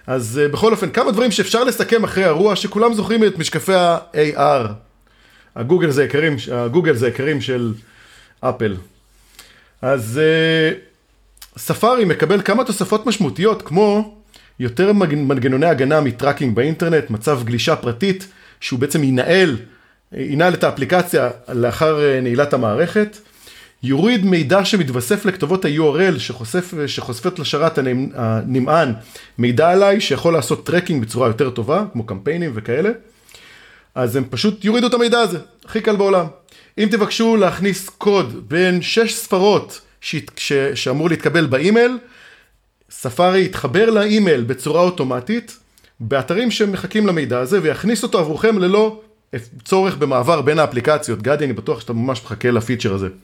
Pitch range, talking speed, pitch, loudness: 130-200 Hz, 130 wpm, 160 Hz, -17 LUFS